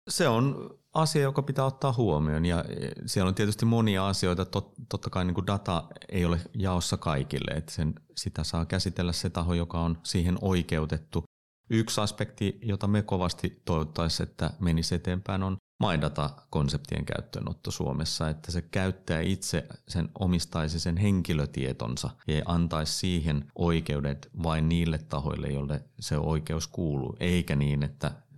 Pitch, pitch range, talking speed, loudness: 90 Hz, 80-100 Hz, 135 wpm, -30 LUFS